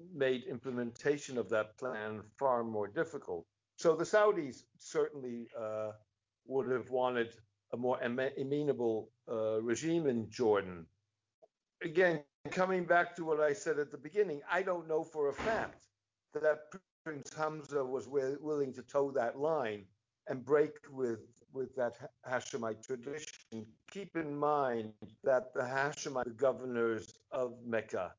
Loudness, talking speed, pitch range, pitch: -36 LUFS, 140 wpm, 115-150 Hz, 130 Hz